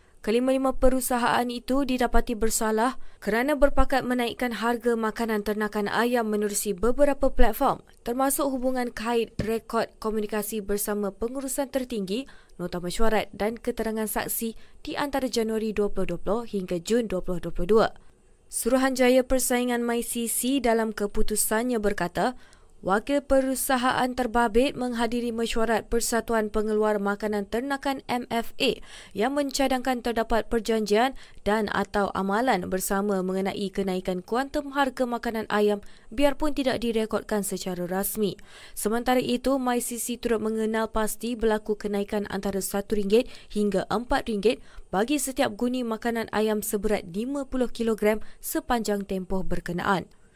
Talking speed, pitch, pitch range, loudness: 110 wpm, 225 Hz, 210-250 Hz, -26 LUFS